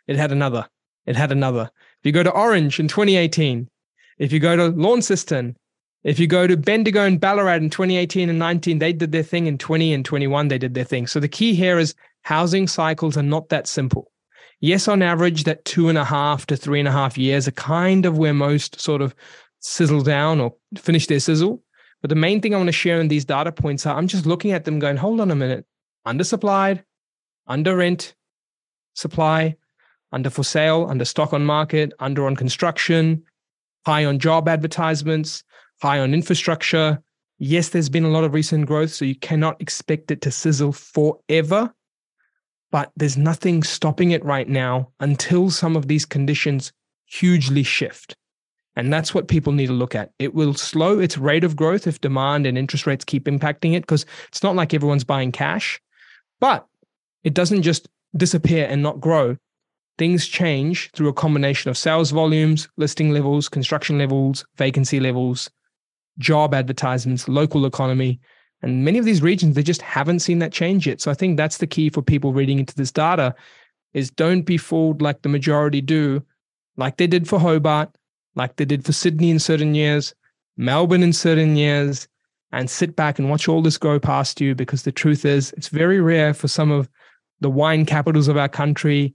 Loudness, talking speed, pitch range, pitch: -19 LUFS, 190 wpm, 140-170 Hz, 155 Hz